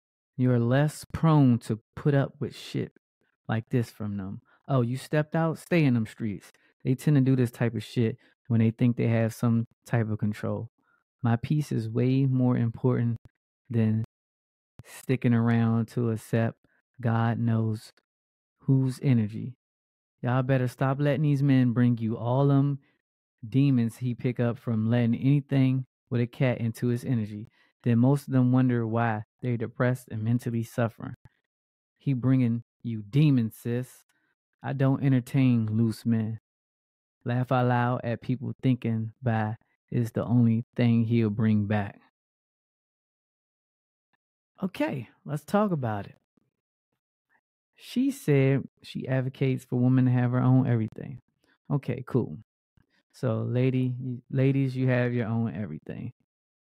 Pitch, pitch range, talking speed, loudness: 120 Hz, 115-130 Hz, 145 wpm, -27 LUFS